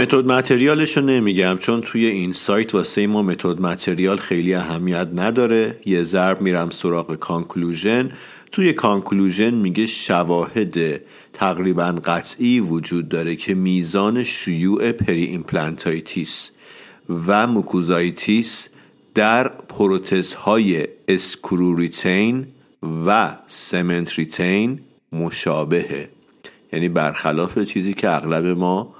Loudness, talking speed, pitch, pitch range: -19 LUFS, 105 wpm, 95 Hz, 85-110 Hz